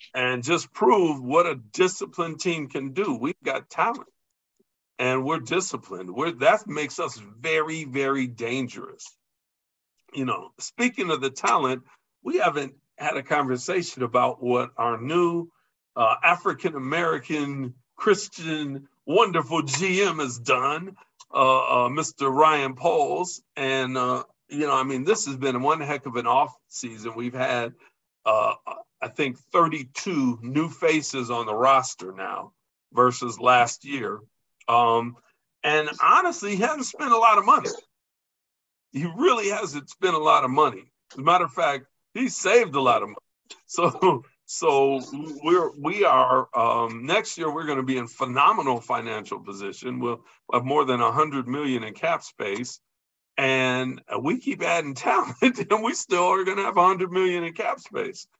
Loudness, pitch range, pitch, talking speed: -24 LUFS, 125-180 Hz, 145 Hz, 155 wpm